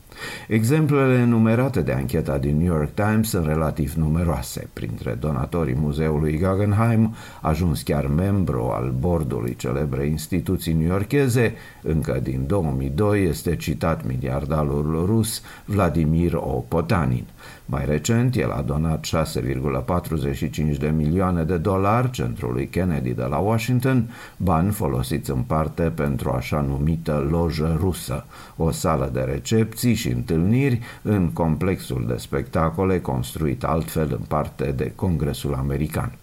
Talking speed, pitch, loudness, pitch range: 125 wpm, 80 Hz, -22 LUFS, 75-105 Hz